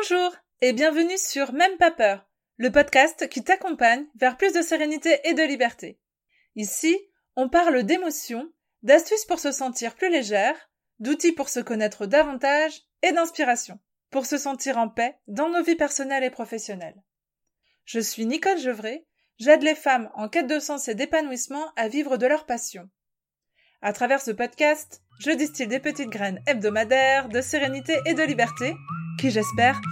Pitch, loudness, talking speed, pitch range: 275 Hz, -23 LUFS, 160 wpm, 235-310 Hz